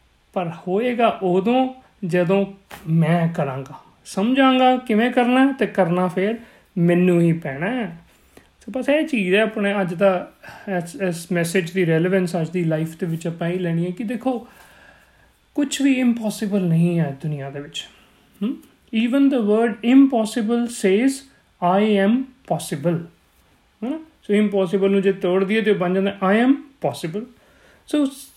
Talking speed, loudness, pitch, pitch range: 140 wpm, -20 LUFS, 195 Hz, 175-240 Hz